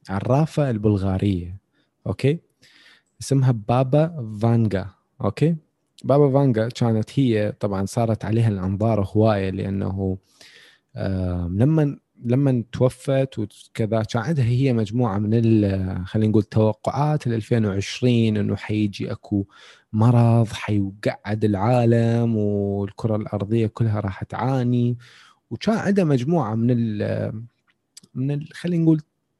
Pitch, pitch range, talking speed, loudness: 115 Hz, 105-130 Hz, 105 wpm, -22 LUFS